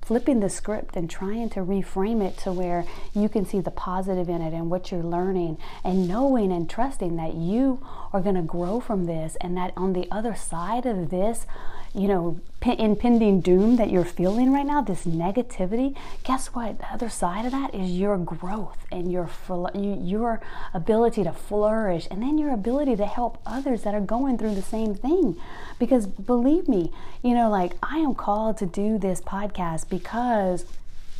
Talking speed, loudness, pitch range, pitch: 190 wpm, -25 LUFS, 180-235 Hz, 200 Hz